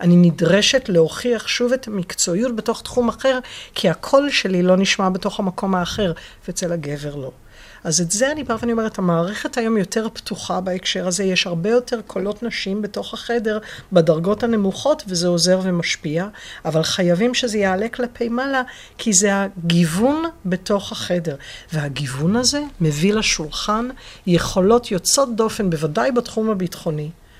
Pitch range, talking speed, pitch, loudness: 175-235 Hz, 140 wpm, 195 Hz, -19 LUFS